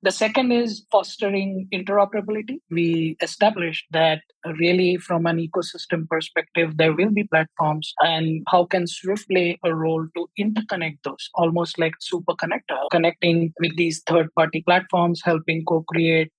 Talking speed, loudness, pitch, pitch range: 145 wpm, -22 LUFS, 170 Hz, 165-190 Hz